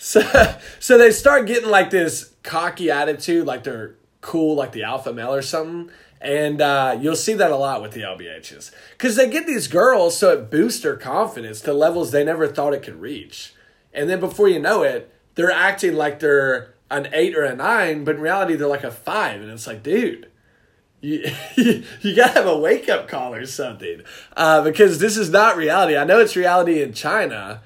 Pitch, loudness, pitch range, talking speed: 160 Hz, -18 LUFS, 140-220 Hz, 205 wpm